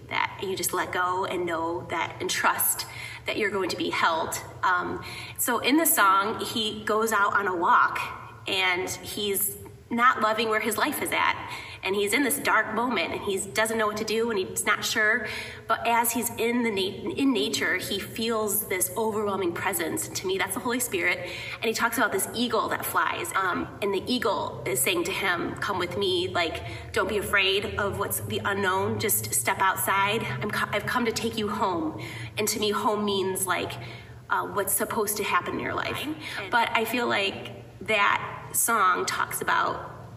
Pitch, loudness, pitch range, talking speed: 215 Hz, -26 LUFS, 195-235 Hz, 200 wpm